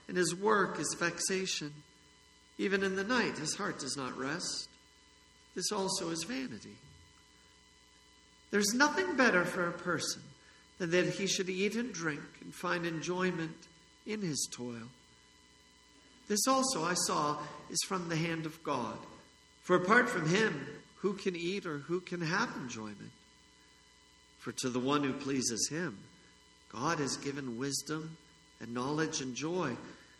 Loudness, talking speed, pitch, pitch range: -34 LUFS, 150 wpm, 170 Hz, 145-195 Hz